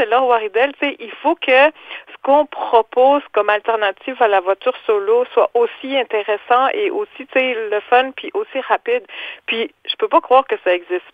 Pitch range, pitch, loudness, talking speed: 225-330 Hz, 260 Hz, -17 LUFS, 180 wpm